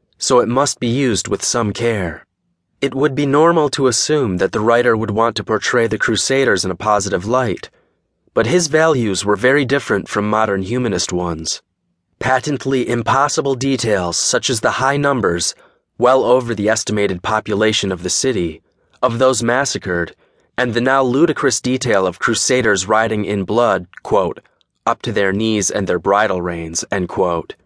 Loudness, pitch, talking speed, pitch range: -16 LUFS, 115 Hz, 165 wpm, 100-130 Hz